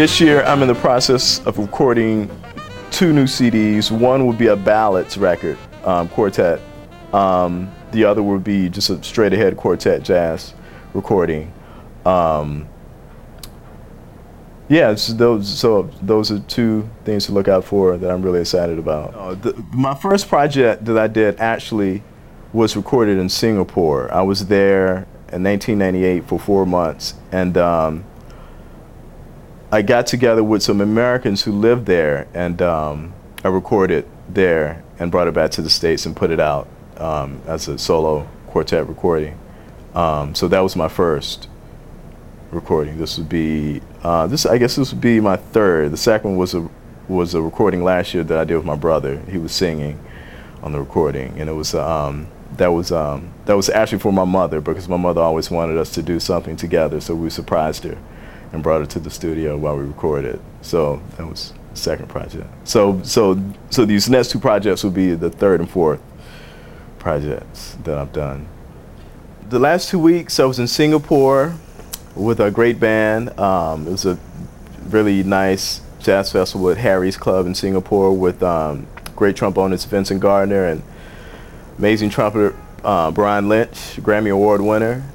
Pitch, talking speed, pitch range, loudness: 95 Hz, 170 wpm, 85-110 Hz, -17 LUFS